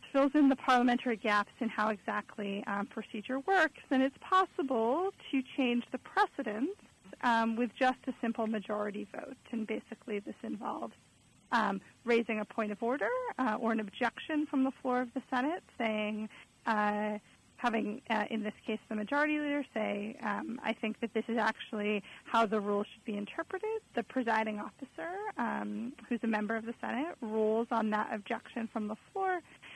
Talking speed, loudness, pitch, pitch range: 175 wpm, -34 LUFS, 230 Hz, 215-265 Hz